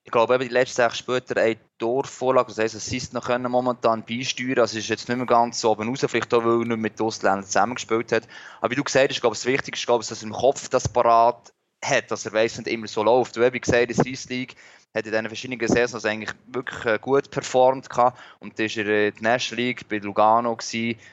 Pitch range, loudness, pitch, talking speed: 110-125 Hz, -23 LUFS, 115 Hz, 230 wpm